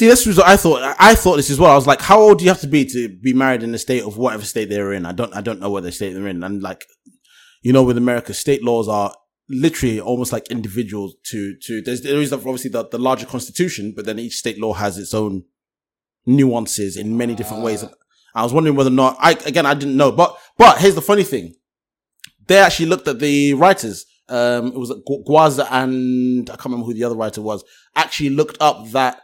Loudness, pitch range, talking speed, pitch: -16 LUFS, 110-145 Hz, 245 wpm, 125 Hz